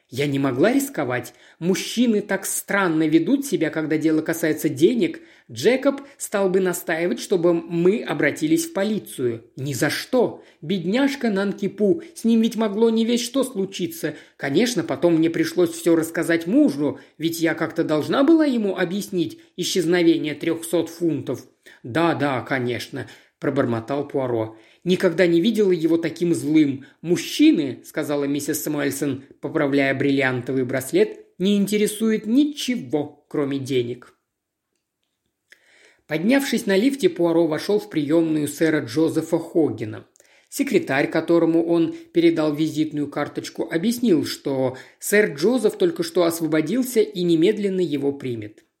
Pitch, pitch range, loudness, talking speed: 170 Hz, 150-205 Hz, -21 LUFS, 125 wpm